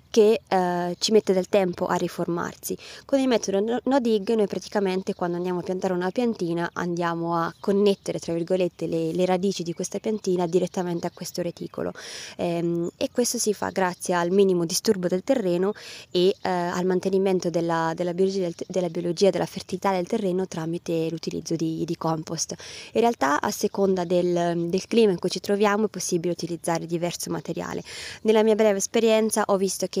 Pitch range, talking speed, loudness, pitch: 175-200 Hz, 180 wpm, -25 LUFS, 185 Hz